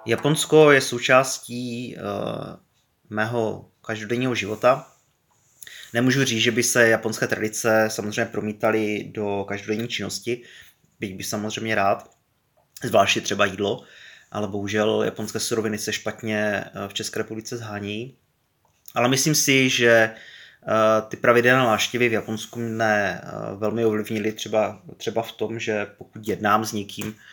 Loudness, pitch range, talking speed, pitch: -22 LUFS, 105-120 Hz, 125 wpm, 110 Hz